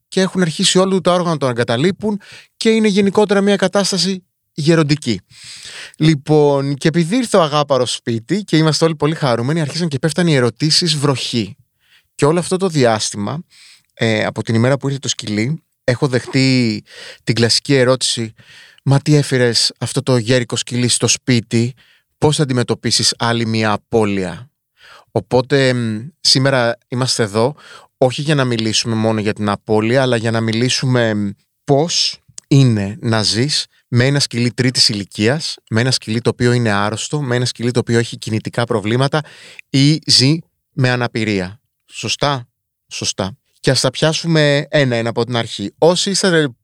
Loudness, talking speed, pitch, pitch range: -16 LUFS, 155 wpm, 130 Hz, 115-150 Hz